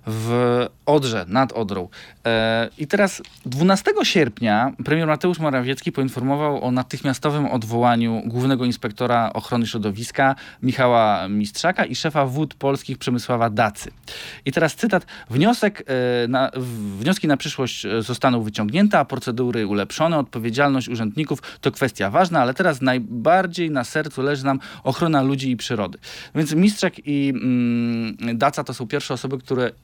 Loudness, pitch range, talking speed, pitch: -21 LUFS, 120-150 Hz, 140 wpm, 130 Hz